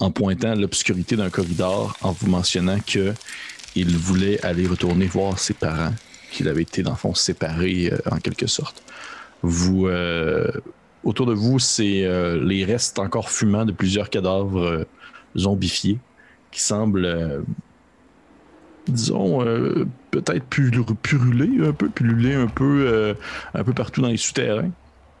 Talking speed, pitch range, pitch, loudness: 150 wpm, 90-115 Hz, 95 Hz, -21 LUFS